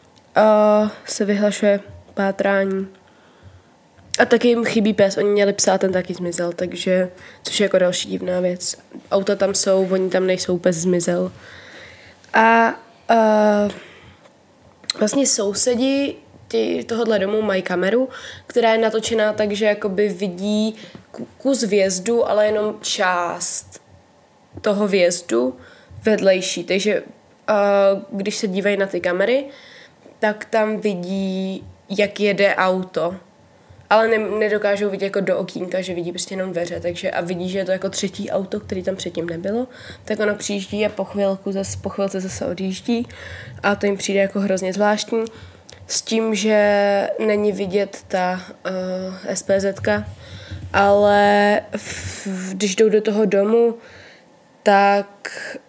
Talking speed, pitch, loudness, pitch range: 135 wpm, 200 Hz, -19 LUFS, 185-215 Hz